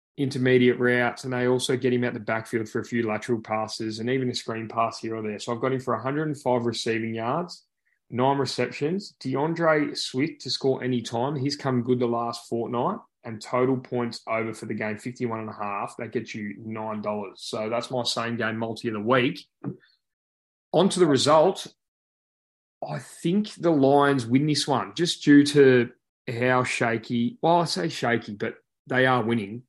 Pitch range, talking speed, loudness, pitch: 115-135 Hz, 190 wpm, -25 LUFS, 125 Hz